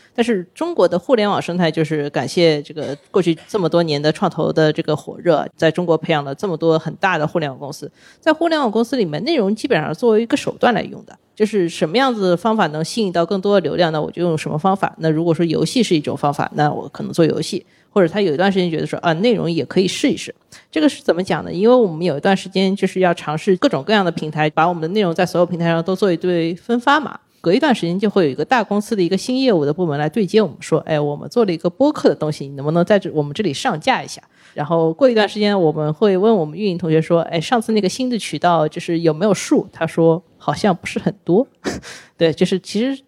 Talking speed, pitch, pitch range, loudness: 390 characters per minute, 175 Hz, 160-210 Hz, -18 LUFS